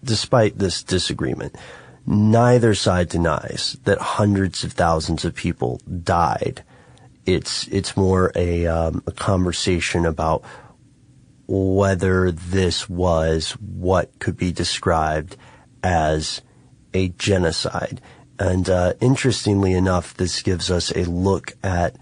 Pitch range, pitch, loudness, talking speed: 85-100 Hz, 95 Hz, -20 LUFS, 110 wpm